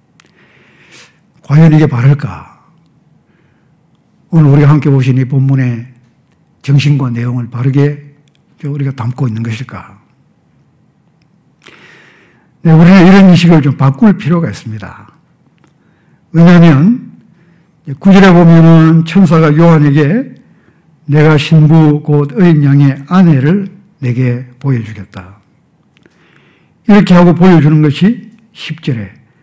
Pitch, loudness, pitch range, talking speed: 150 Hz, -8 LUFS, 135-170 Hz, 215 characters per minute